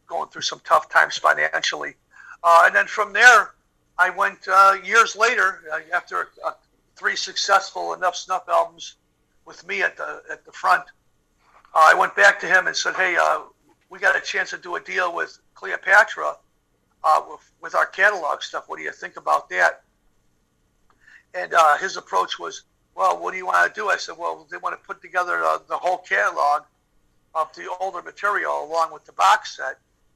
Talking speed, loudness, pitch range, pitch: 190 wpm, -20 LUFS, 155-195 Hz, 180 Hz